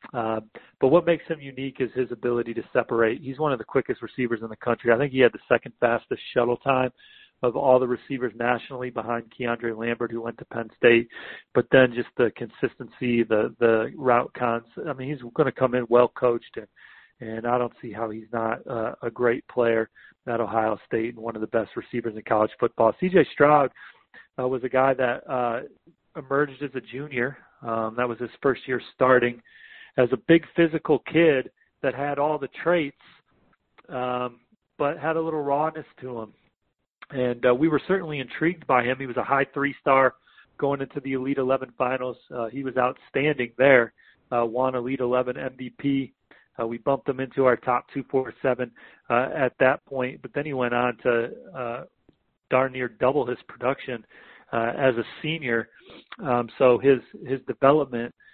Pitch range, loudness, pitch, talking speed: 120-140 Hz, -25 LUFS, 125 Hz, 190 wpm